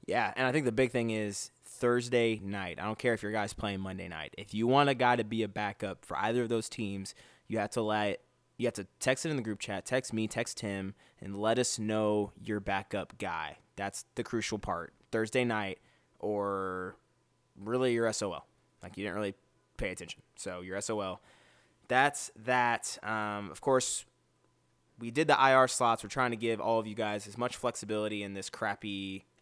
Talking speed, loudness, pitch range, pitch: 205 wpm, -33 LUFS, 100-120 Hz, 110 Hz